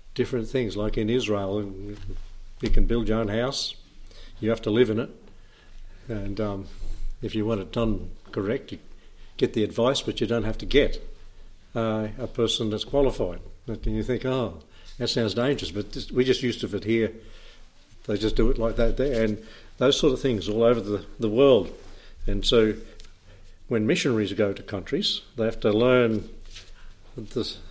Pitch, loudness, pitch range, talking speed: 110 Hz, -26 LUFS, 100-115 Hz, 180 wpm